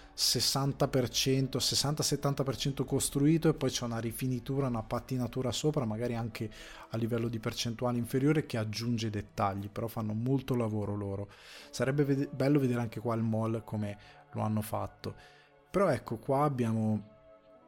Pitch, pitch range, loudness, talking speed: 120 Hz, 110-135 Hz, -32 LUFS, 145 wpm